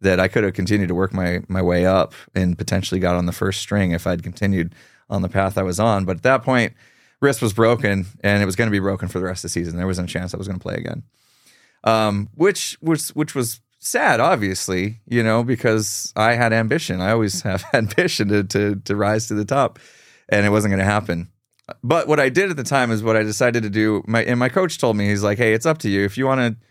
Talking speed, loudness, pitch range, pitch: 265 wpm, -20 LUFS, 95-120 Hz, 105 Hz